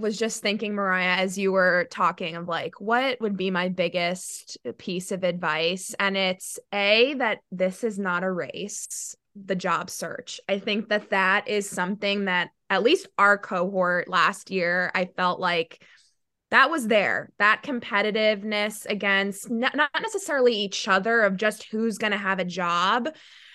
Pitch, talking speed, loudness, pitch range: 200 Hz, 165 wpm, -24 LUFS, 180-215 Hz